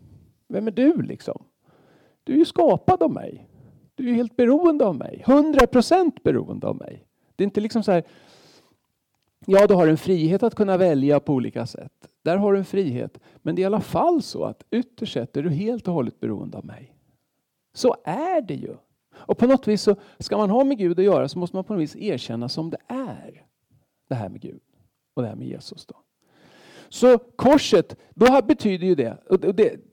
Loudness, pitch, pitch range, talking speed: -21 LUFS, 210 Hz, 180-260 Hz, 205 wpm